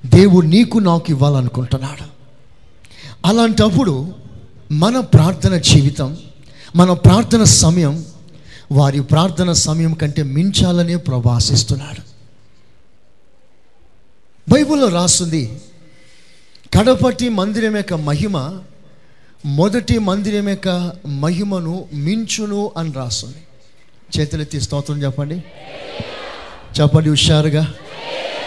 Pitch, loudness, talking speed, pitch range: 155 Hz, -15 LUFS, 75 wpm, 140-180 Hz